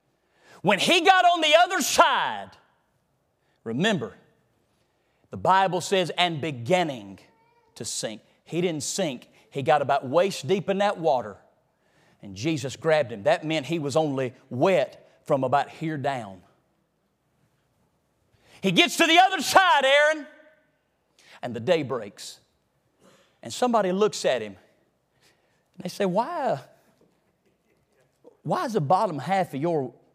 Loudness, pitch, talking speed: -23 LUFS, 180 Hz, 135 wpm